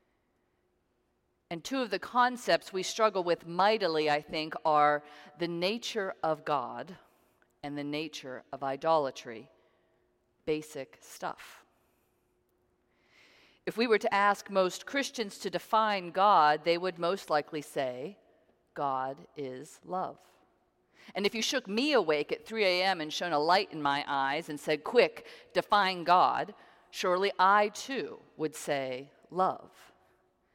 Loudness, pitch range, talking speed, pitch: -30 LUFS, 150-200 Hz, 135 wpm, 170 Hz